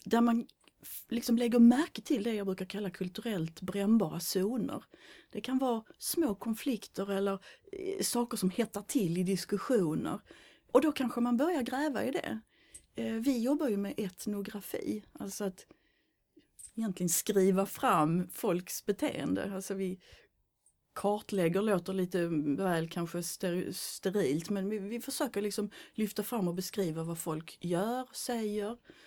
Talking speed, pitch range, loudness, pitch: 140 wpm, 185-240 Hz, -33 LUFS, 205 Hz